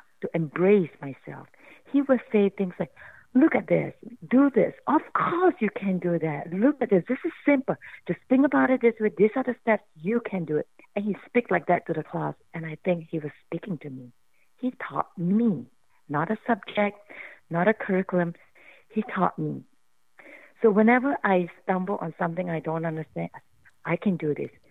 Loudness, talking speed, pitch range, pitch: -26 LUFS, 195 wpm, 165-235 Hz, 190 Hz